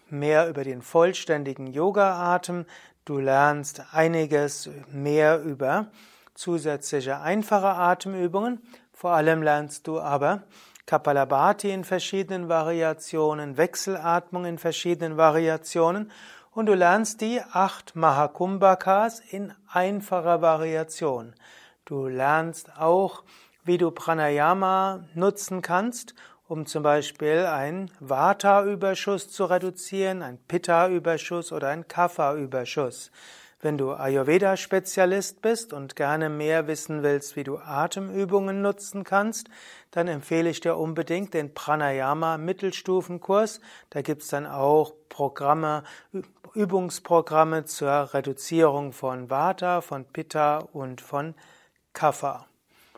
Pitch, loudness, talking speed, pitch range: 165 Hz, -25 LUFS, 105 wpm, 150-190 Hz